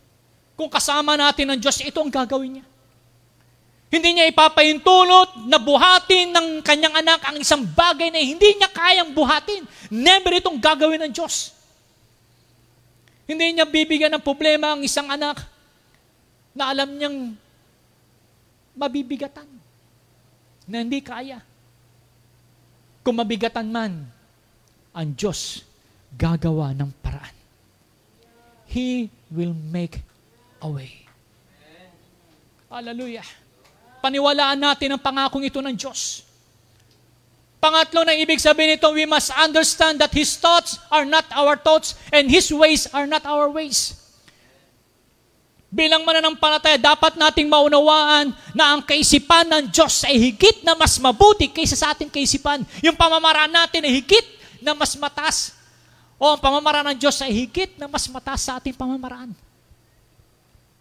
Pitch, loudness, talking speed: 280 Hz, -17 LUFS, 125 wpm